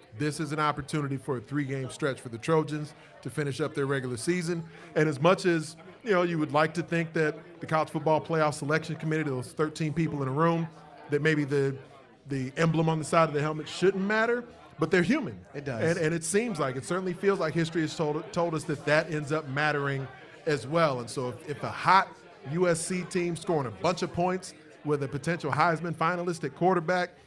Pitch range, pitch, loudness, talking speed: 145-170 Hz, 155 Hz, -29 LUFS, 215 wpm